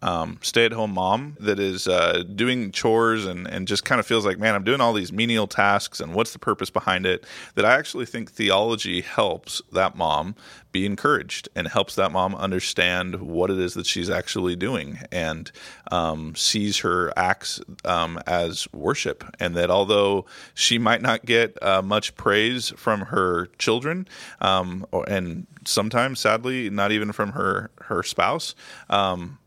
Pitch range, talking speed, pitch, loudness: 90-110 Hz, 170 wpm, 100 Hz, -23 LUFS